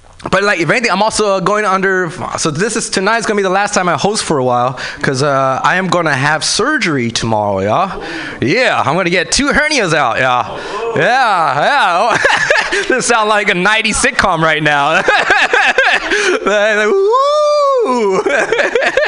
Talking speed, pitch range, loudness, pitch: 160 wpm, 150-220 Hz, -12 LUFS, 195 Hz